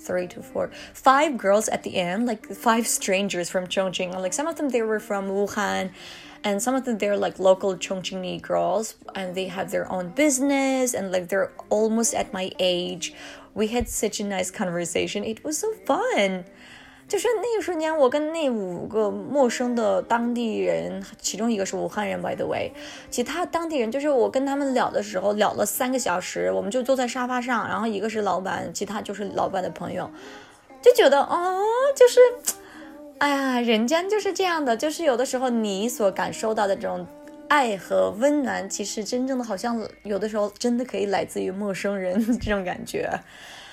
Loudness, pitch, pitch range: -24 LUFS, 220 Hz, 190-270 Hz